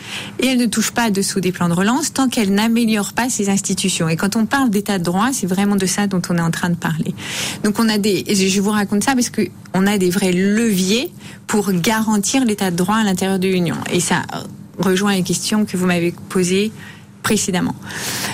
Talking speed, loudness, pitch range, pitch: 225 wpm, -17 LUFS, 185-215 Hz, 200 Hz